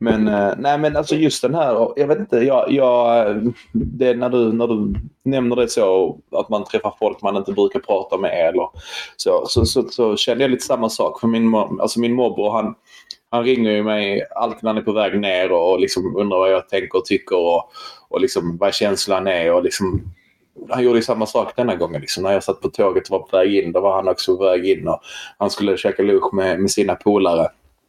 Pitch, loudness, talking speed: 125 Hz, -18 LUFS, 230 wpm